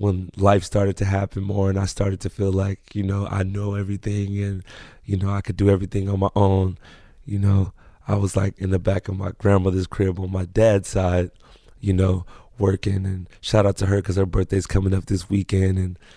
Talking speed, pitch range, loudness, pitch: 220 wpm, 95-100 Hz, -22 LUFS, 95 Hz